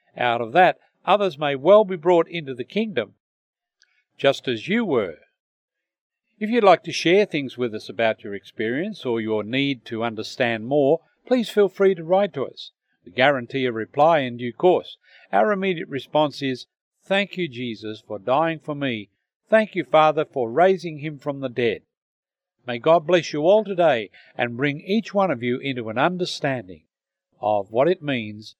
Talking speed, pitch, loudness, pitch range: 180 wpm, 150 Hz, -22 LUFS, 120-185 Hz